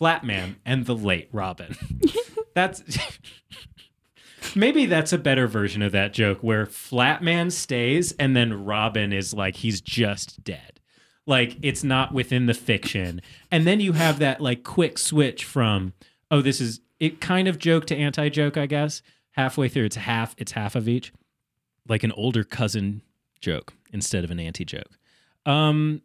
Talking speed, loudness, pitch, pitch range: 165 wpm, -23 LUFS, 125 Hz, 110-150 Hz